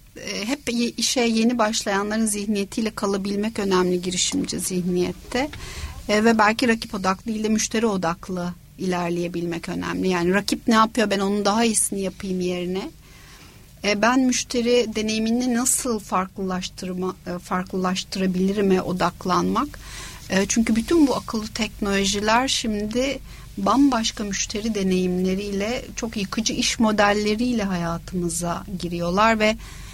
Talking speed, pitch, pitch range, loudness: 110 wpm, 205 Hz, 185-225 Hz, -22 LUFS